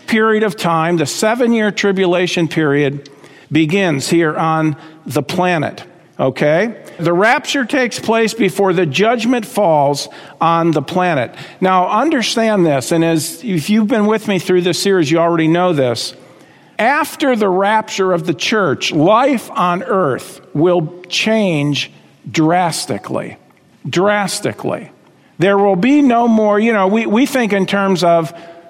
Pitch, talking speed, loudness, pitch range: 180 Hz, 140 wpm, -14 LUFS, 165-215 Hz